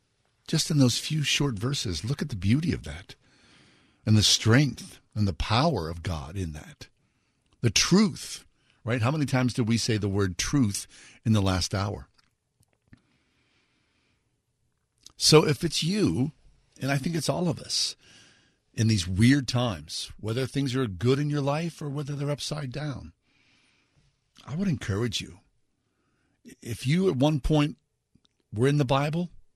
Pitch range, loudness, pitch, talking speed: 110-145 Hz, -26 LUFS, 130 Hz, 160 wpm